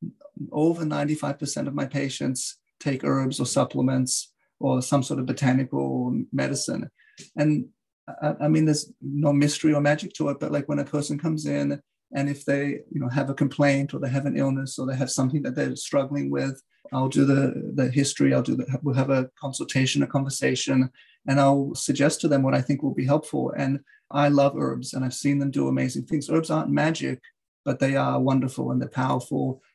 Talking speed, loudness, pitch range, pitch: 200 wpm, -25 LUFS, 130-145 Hz, 140 Hz